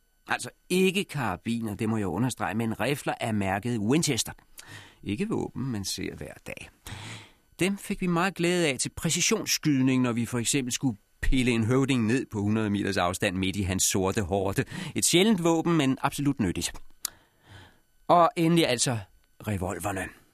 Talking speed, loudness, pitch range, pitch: 160 wpm, -27 LUFS, 105-150 Hz, 120 Hz